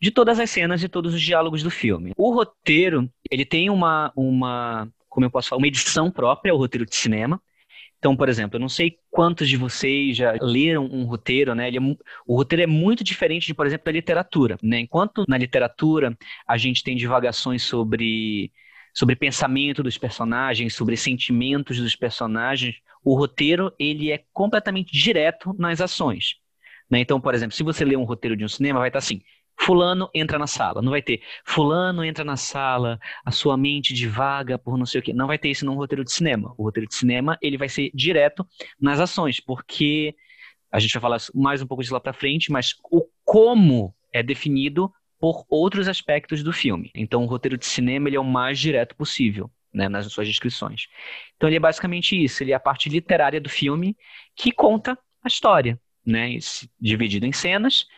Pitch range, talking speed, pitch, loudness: 125-160 Hz, 195 wpm, 140 Hz, -21 LUFS